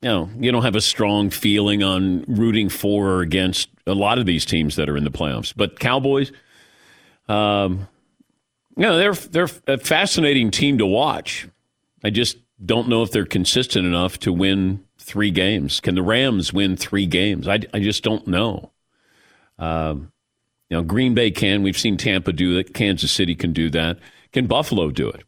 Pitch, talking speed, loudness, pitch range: 100 Hz, 190 wpm, -19 LUFS, 90-110 Hz